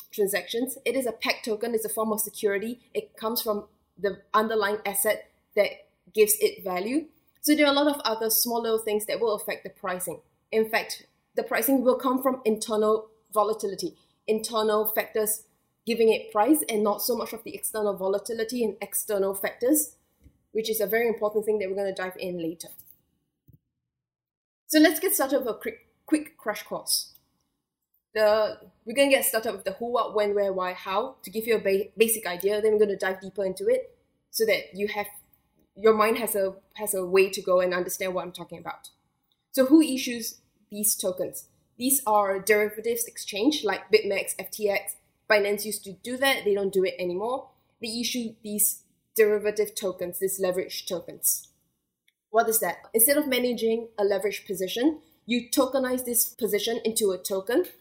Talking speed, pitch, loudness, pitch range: 180 wpm, 215 Hz, -26 LUFS, 200-235 Hz